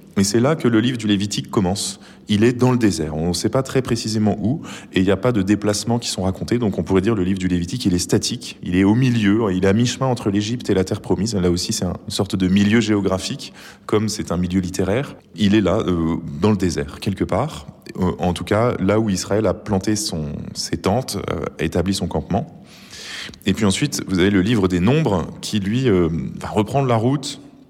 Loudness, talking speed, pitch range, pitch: -20 LUFS, 240 wpm, 90-110 Hz, 100 Hz